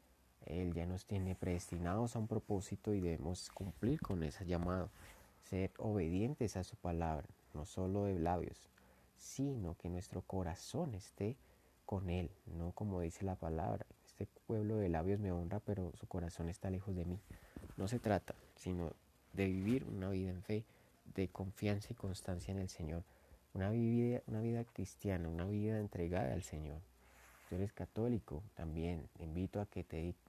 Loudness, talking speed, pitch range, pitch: -42 LUFS, 170 wpm, 85-105 Hz, 95 Hz